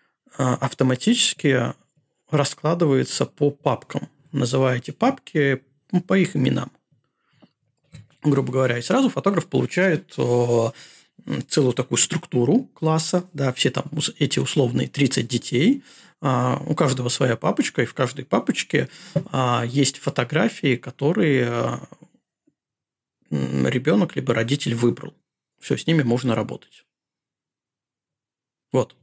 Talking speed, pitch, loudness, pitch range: 95 wpm, 135 Hz, -21 LUFS, 125-155 Hz